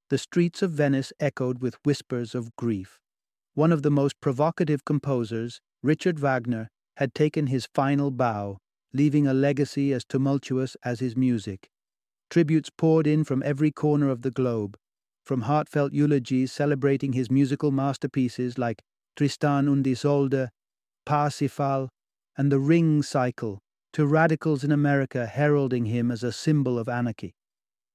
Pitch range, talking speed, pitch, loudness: 120-145 Hz, 140 wpm, 135 Hz, -25 LUFS